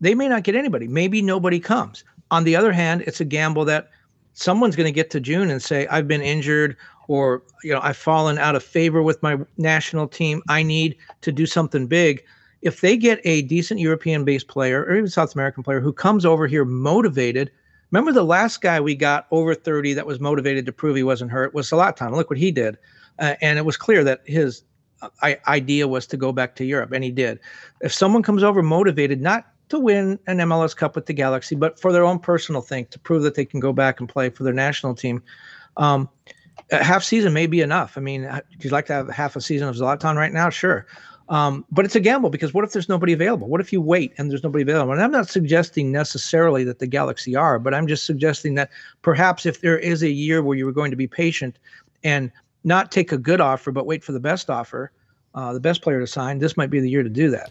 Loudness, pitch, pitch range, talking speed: -20 LUFS, 155 Hz, 135-170 Hz, 240 wpm